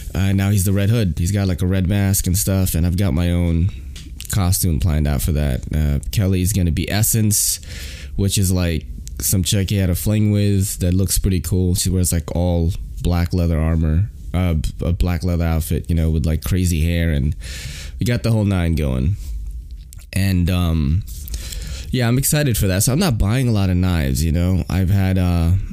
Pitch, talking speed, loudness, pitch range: 90 Hz, 205 wpm, -19 LUFS, 80-95 Hz